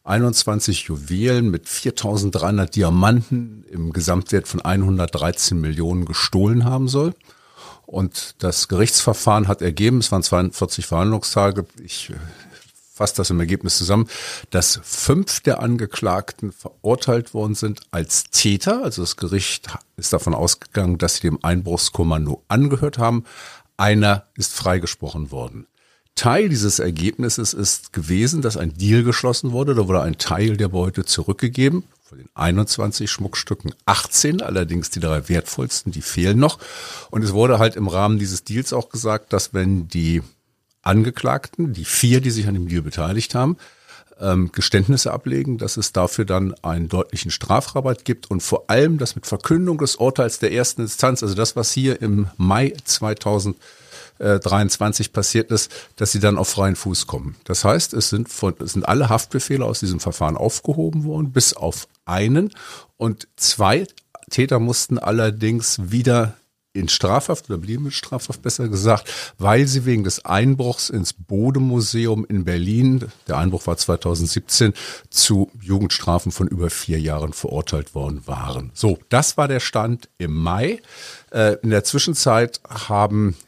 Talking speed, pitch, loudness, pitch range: 150 wpm, 105 Hz, -19 LUFS, 90-120 Hz